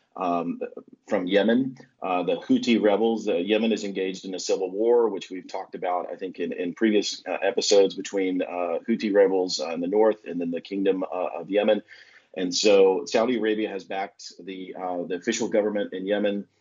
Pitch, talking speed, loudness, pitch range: 100 Hz, 195 wpm, -25 LUFS, 95-110 Hz